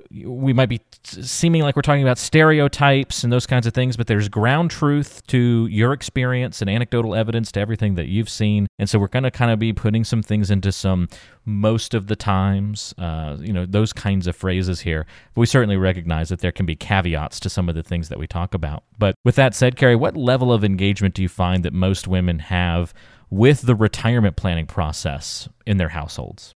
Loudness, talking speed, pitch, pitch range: -20 LUFS, 215 wpm, 105 Hz, 95-125 Hz